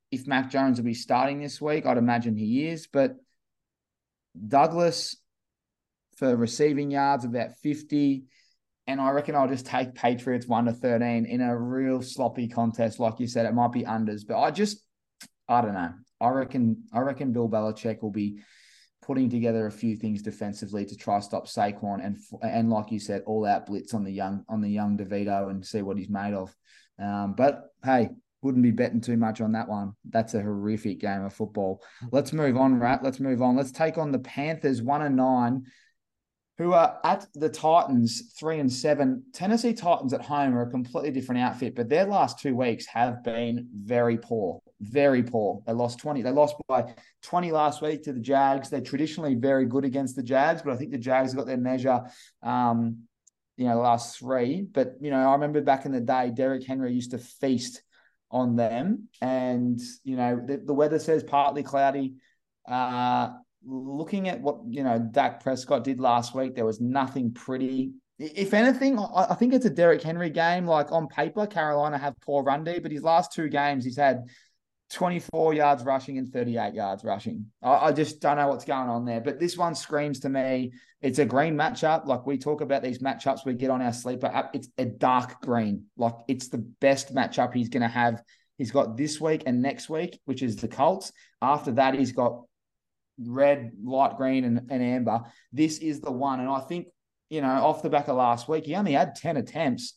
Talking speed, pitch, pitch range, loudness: 200 wpm, 130 Hz, 120-145 Hz, -26 LUFS